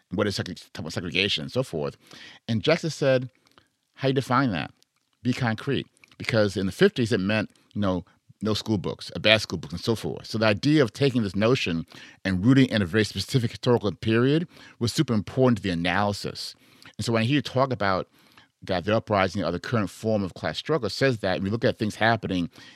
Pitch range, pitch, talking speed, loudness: 95-130 Hz, 110 Hz, 210 wpm, -25 LUFS